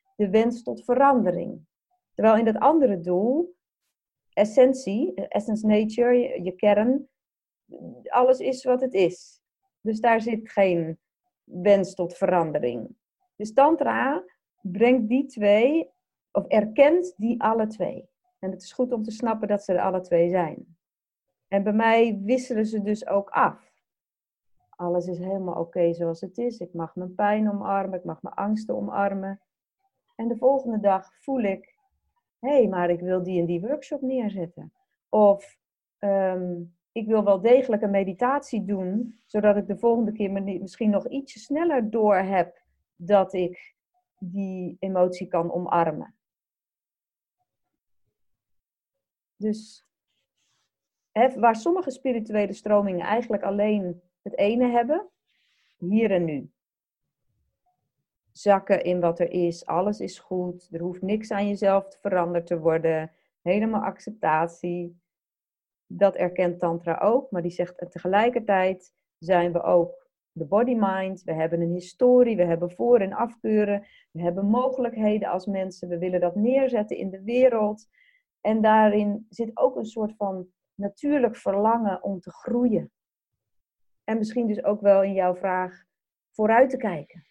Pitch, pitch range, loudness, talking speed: 205 Hz, 180-235 Hz, -24 LUFS, 145 wpm